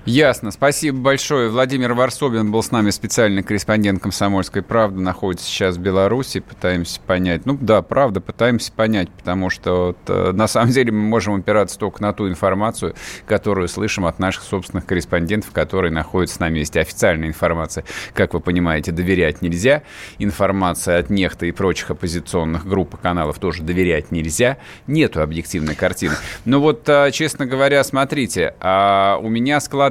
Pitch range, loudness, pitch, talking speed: 90-115 Hz, -18 LUFS, 100 Hz, 155 wpm